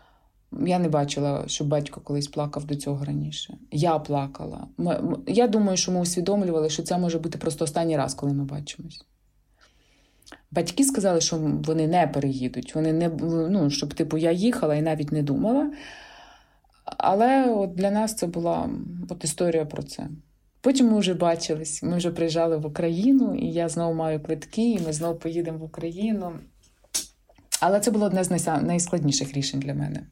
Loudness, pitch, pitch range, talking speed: -25 LUFS, 165 Hz, 150-180 Hz, 165 wpm